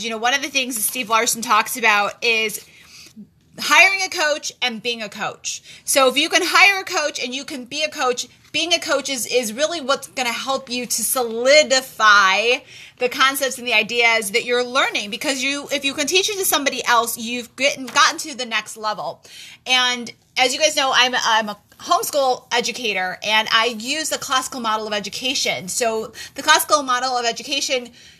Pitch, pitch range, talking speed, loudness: 255 Hz, 230-285 Hz, 200 wpm, -18 LUFS